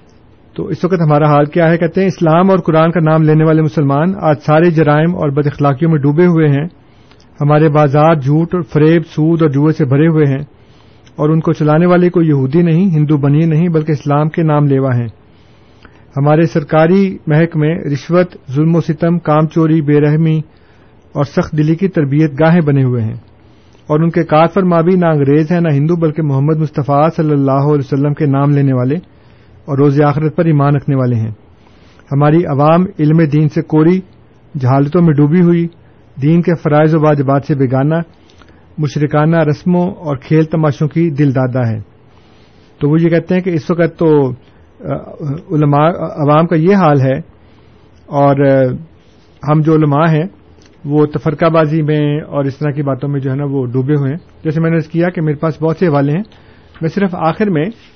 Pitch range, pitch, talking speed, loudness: 140-165 Hz, 150 Hz, 195 wpm, -12 LUFS